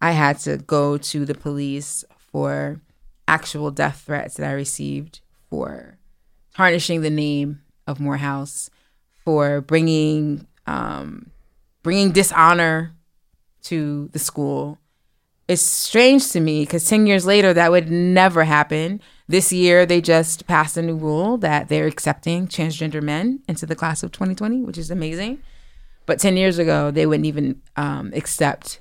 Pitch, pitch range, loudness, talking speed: 160 Hz, 145-175 Hz, -19 LUFS, 145 wpm